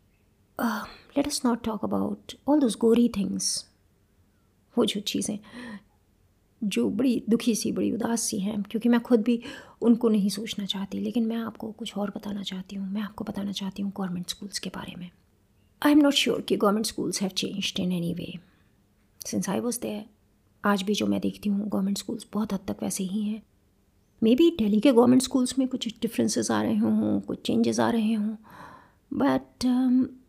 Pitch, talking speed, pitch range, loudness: 205 Hz, 180 wpm, 180-235 Hz, -26 LUFS